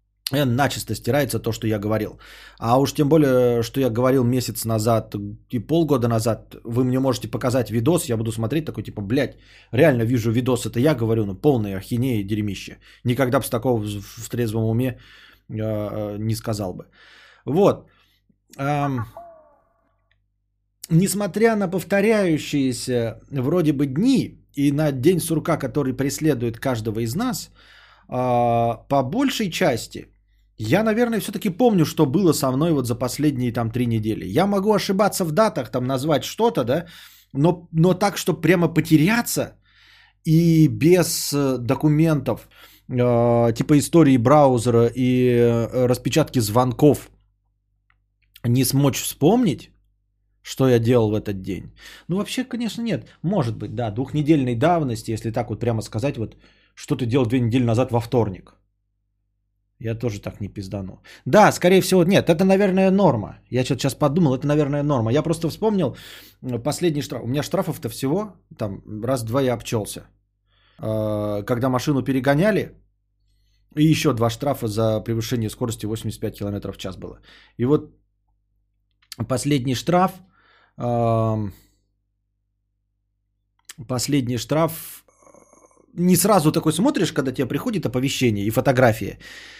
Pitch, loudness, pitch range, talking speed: 125 Hz, -21 LUFS, 110-150 Hz, 140 wpm